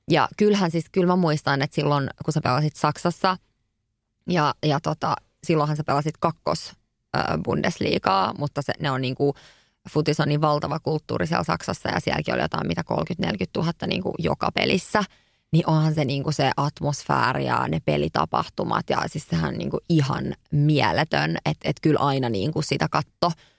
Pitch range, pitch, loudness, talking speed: 140-160 Hz, 150 Hz, -24 LUFS, 165 wpm